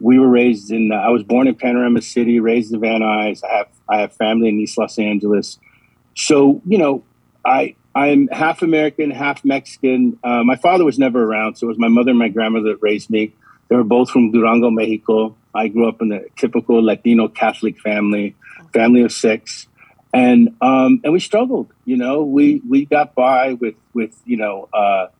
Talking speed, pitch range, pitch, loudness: 200 wpm, 110-130 Hz, 120 Hz, -16 LUFS